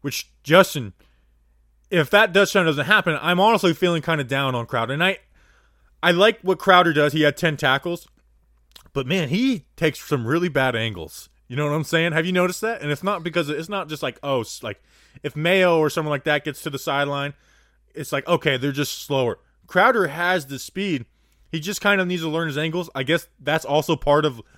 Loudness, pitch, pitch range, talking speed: -21 LUFS, 155 Hz, 140-180 Hz, 220 wpm